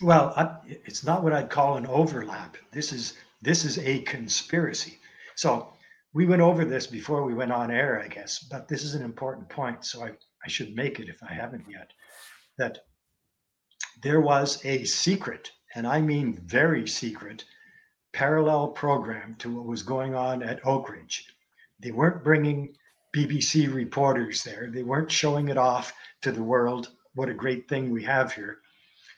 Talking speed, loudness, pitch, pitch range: 175 wpm, -27 LUFS, 140 Hz, 125-155 Hz